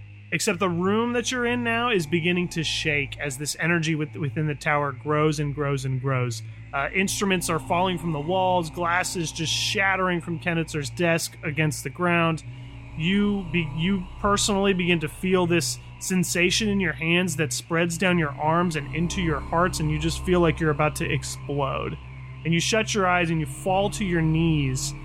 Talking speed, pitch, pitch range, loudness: 190 wpm, 165 Hz, 145-180 Hz, -24 LUFS